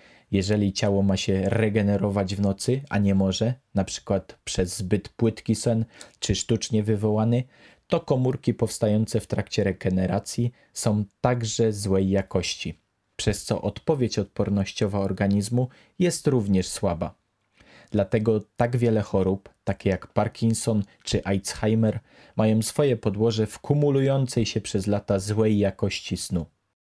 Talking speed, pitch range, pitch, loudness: 125 wpm, 100-115 Hz, 105 Hz, -25 LUFS